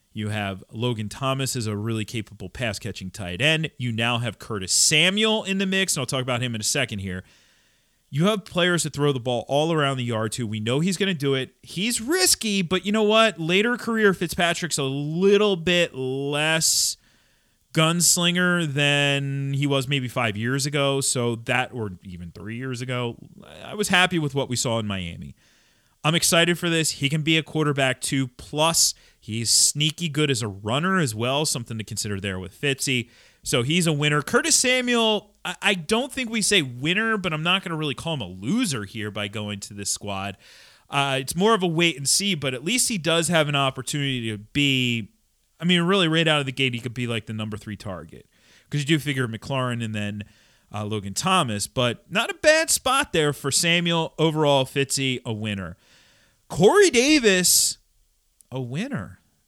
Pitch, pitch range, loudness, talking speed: 140 Hz, 115-170 Hz, -22 LUFS, 200 wpm